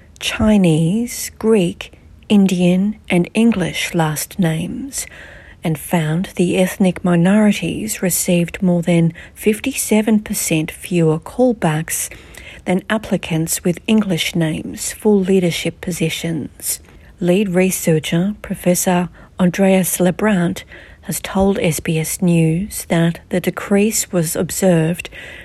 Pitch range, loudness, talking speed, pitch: 170-200 Hz, -17 LUFS, 95 wpm, 180 Hz